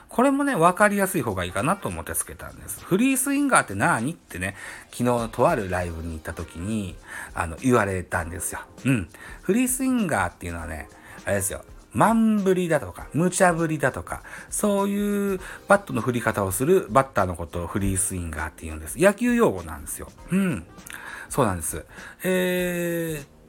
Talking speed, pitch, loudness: 400 characters per minute, 125 Hz, -24 LUFS